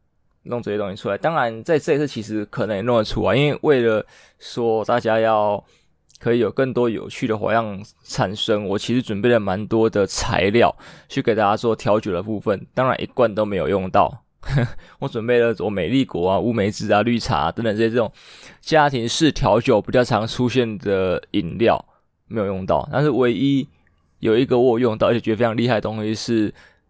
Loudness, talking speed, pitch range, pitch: -20 LUFS, 295 characters per minute, 105-120 Hz, 115 Hz